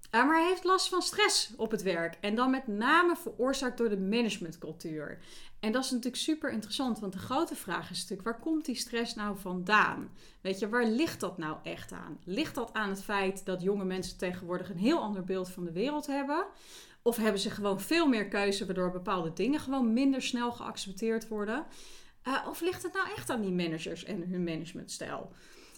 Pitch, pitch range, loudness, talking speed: 225 Hz, 190-270 Hz, -32 LUFS, 205 wpm